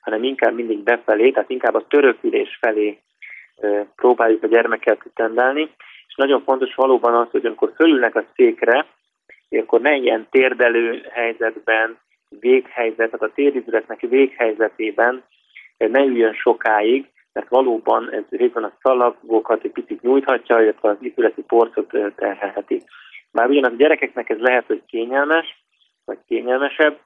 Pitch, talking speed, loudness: 130 Hz, 140 wpm, -18 LUFS